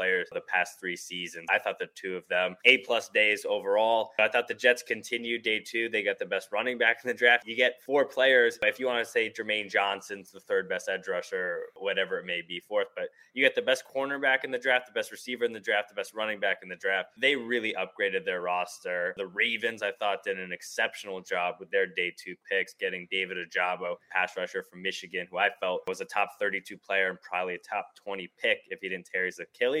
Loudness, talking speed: -28 LUFS, 240 wpm